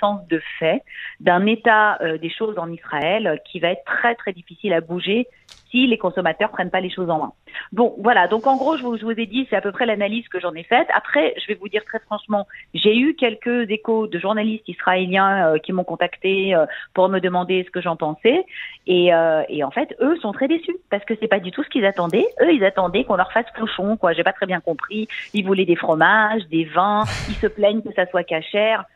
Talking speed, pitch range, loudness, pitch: 240 wpm, 180-220 Hz, -20 LUFS, 200 Hz